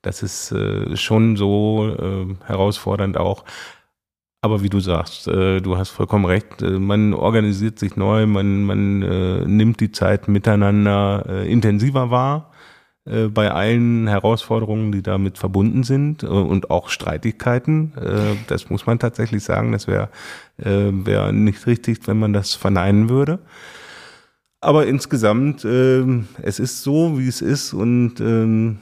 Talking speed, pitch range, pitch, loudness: 150 wpm, 100-120 Hz, 105 Hz, -19 LUFS